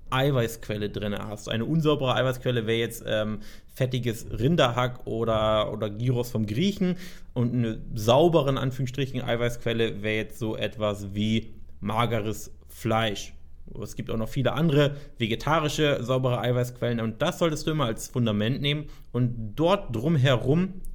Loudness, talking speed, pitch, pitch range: -26 LUFS, 140 wpm, 120 Hz, 110-140 Hz